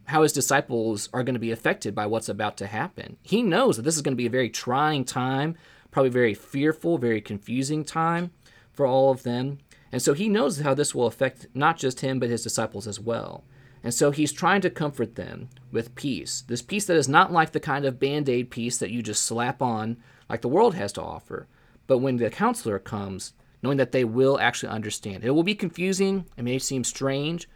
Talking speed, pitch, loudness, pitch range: 220 wpm, 130 Hz, -25 LUFS, 115-150 Hz